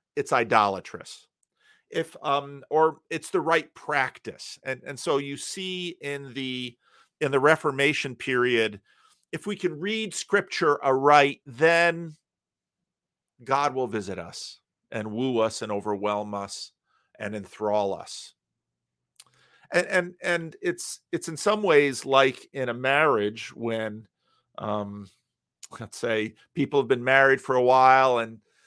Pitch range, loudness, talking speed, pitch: 110-160 Hz, -25 LUFS, 135 wpm, 135 Hz